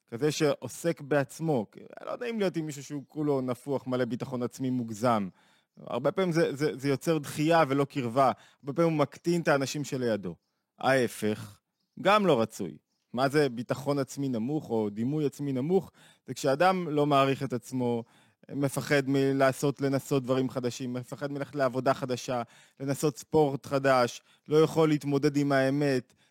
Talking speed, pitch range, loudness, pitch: 150 wpm, 130-150 Hz, -29 LUFS, 140 Hz